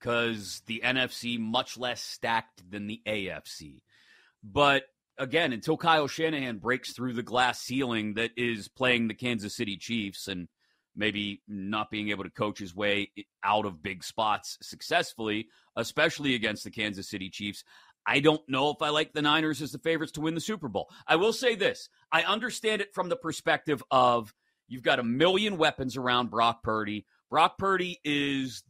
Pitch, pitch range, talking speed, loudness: 120 Hz, 105-150 Hz, 175 wpm, -29 LUFS